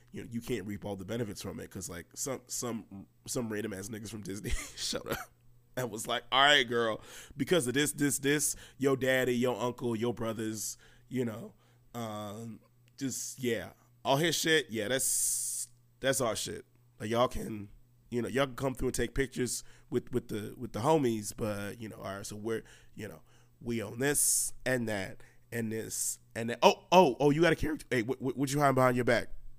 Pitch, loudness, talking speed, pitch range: 120 Hz, -32 LUFS, 215 wpm, 115-130 Hz